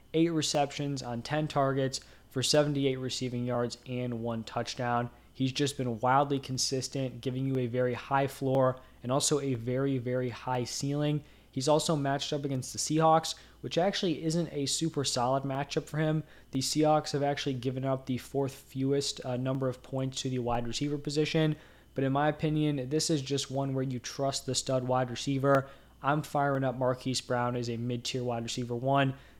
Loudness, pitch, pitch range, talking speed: -31 LUFS, 135 Hz, 125-145 Hz, 185 wpm